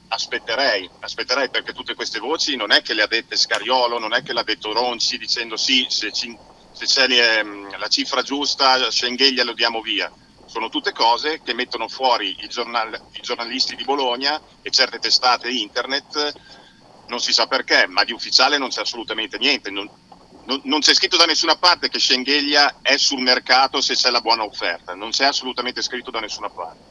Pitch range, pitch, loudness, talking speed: 120-145 Hz, 130 Hz, -18 LUFS, 185 wpm